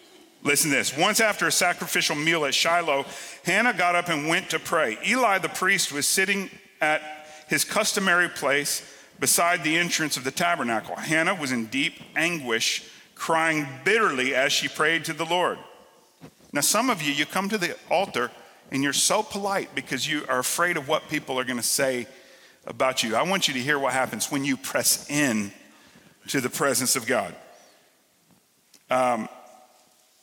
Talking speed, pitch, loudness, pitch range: 175 wpm, 155 Hz, -23 LUFS, 130-175 Hz